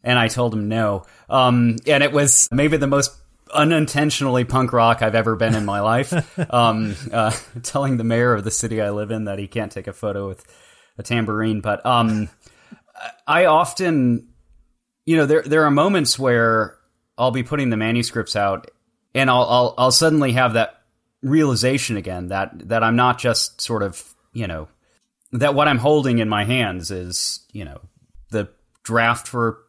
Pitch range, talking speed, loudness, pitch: 110-130 Hz, 180 wpm, -19 LUFS, 115 Hz